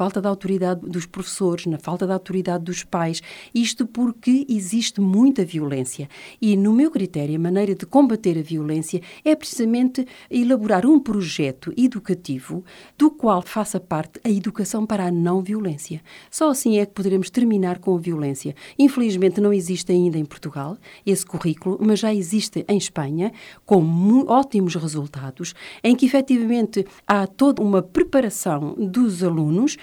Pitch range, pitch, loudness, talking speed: 175-230 Hz, 195 Hz, -21 LUFS, 155 wpm